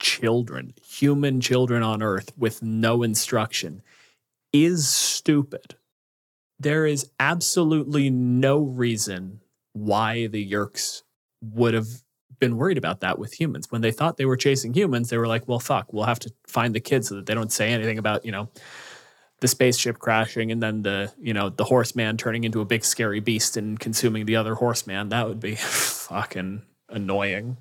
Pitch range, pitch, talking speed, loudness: 110-125 Hz, 115 Hz, 170 wpm, -23 LUFS